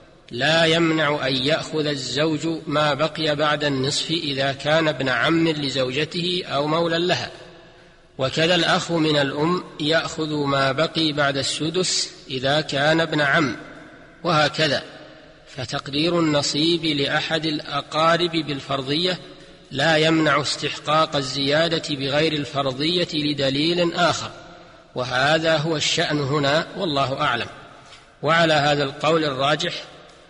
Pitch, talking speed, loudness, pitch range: 155 Hz, 105 wpm, -21 LUFS, 145-165 Hz